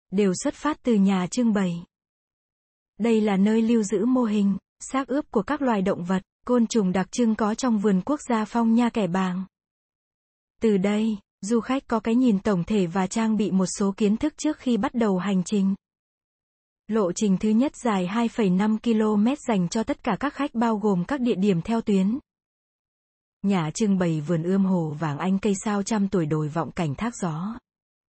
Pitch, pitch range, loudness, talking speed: 215 Hz, 190-235 Hz, -24 LUFS, 200 wpm